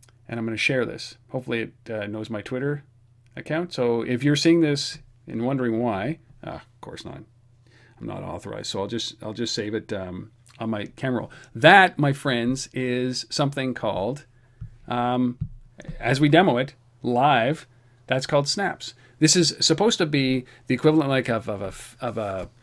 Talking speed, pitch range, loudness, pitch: 180 wpm, 115-140 Hz, -23 LUFS, 125 Hz